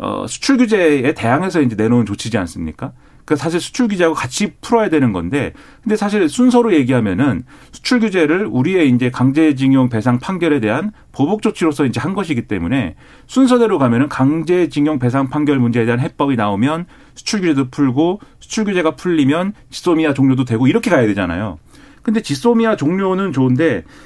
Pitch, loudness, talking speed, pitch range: 150 Hz, -16 LUFS, 395 characters per minute, 130-195 Hz